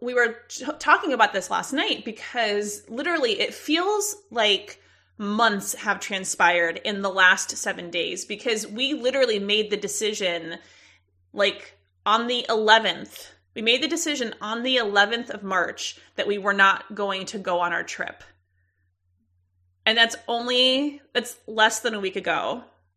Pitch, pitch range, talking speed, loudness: 210 Hz, 185-240 Hz, 155 wpm, -23 LUFS